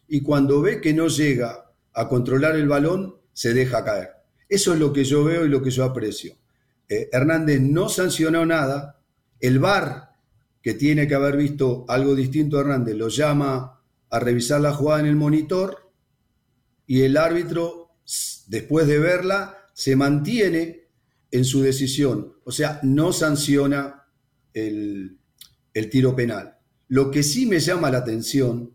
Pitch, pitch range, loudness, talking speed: 140 Hz, 125-155 Hz, -21 LUFS, 155 wpm